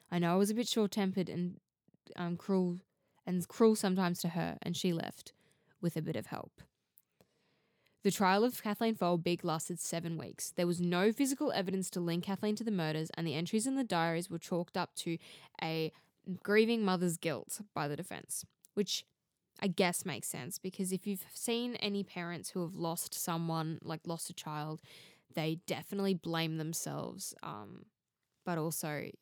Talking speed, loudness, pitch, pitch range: 175 wpm, -36 LUFS, 175 Hz, 165-195 Hz